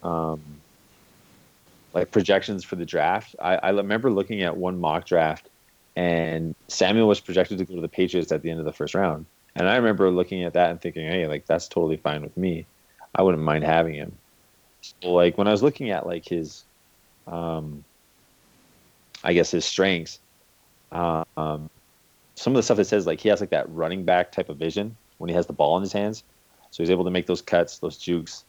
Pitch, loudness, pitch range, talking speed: 90 Hz, -24 LUFS, 80-95 Hz, 210 wpm